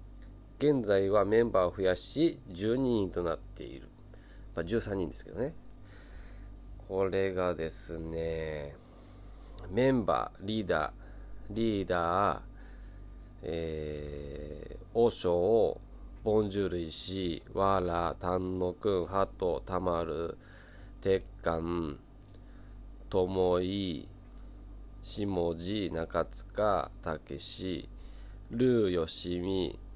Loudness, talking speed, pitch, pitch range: -32 LUFS, 155 characters per minute, 95 Hz, 85-100 Hz